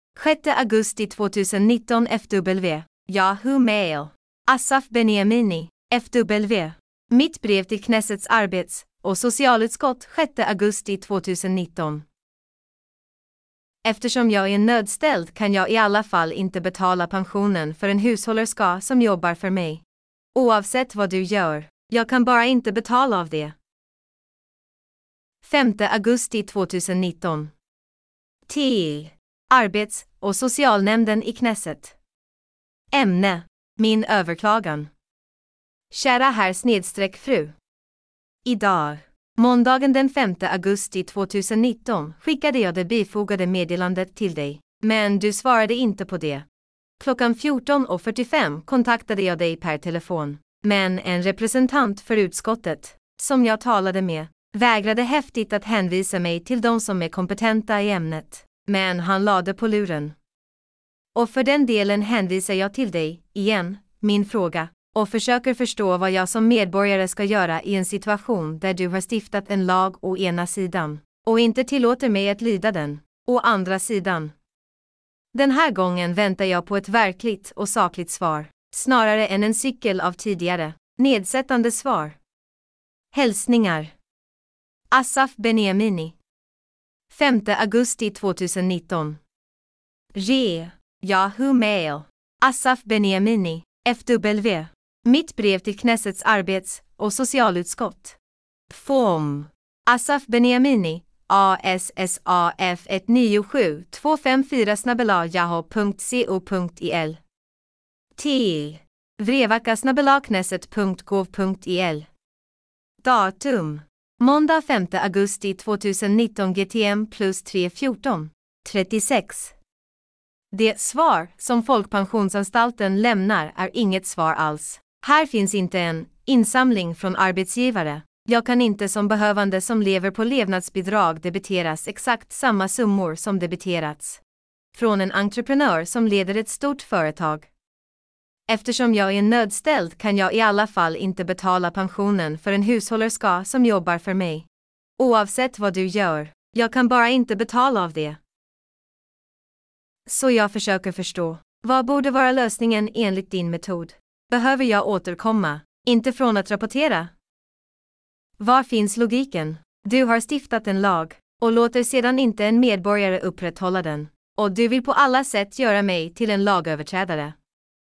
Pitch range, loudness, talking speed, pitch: 185-235 Hz, -21 LUFS, 115 wpm, 205 Hz